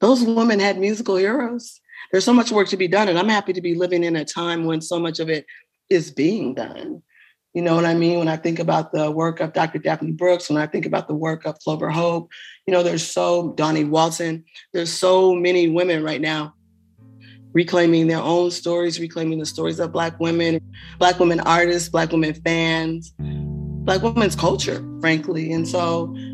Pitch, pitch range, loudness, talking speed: 165 Hz, 160-180 Hz, -20 LUFS, 200 wpm